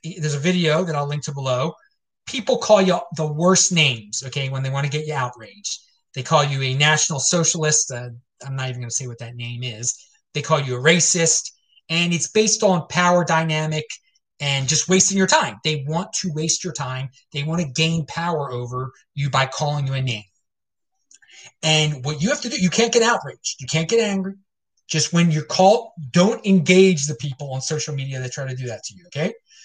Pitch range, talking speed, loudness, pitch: 135-180 Hz, 215 wpm, -20 LUFS, 155 Hz